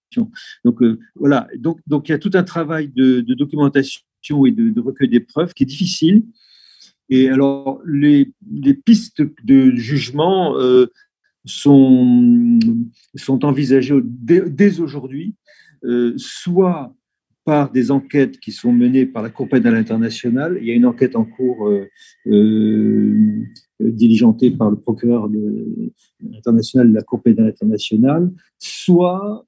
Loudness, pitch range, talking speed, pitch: -15 LUFS, 120-190 Hz, 140 wpm, 140 Hz